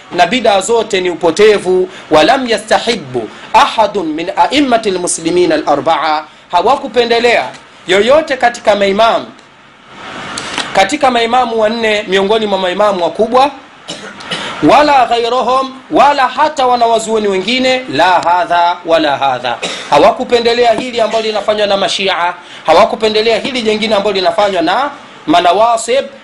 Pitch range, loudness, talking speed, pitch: 190-255 Hz, -11 LUFS, 105 wpm, 225 Hz